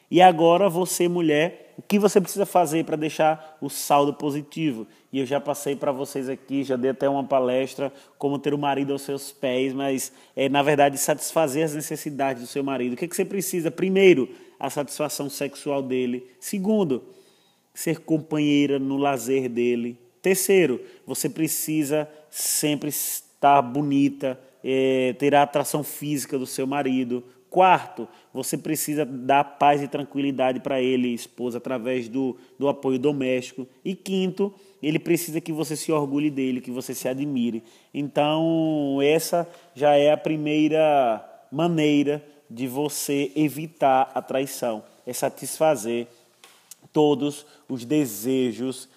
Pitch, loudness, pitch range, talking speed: 145 Hz, -24 LUFS, 130-155 Hz, 145 wpm